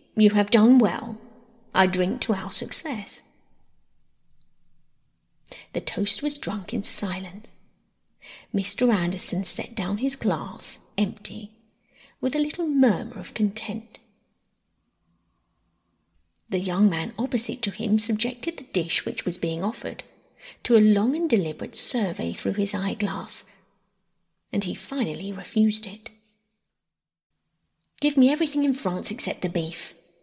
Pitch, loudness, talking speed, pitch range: 210 Hz, -23 LUFS, 125 wpm, 185-235 Hz